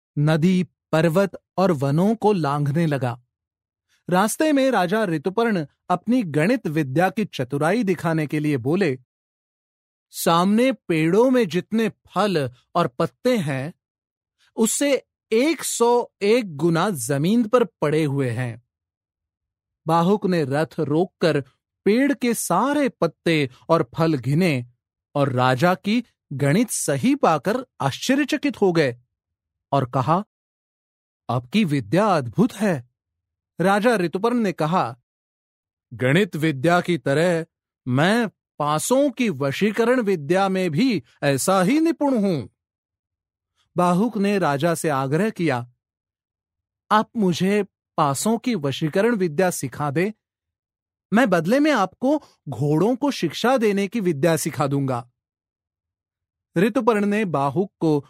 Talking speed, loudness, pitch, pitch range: 115 wpm, -21 LUFS, 170 Hz, 135-210 Hz